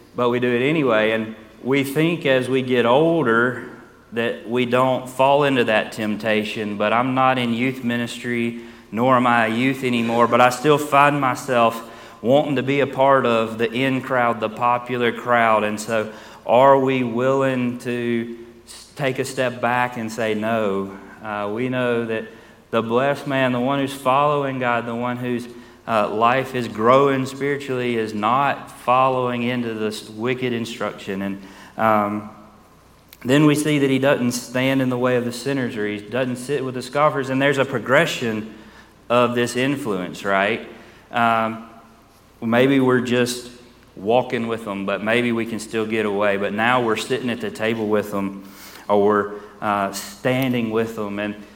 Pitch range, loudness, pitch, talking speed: 110-130 Hz, -20 LUFS, 120 Hz, 170 wpm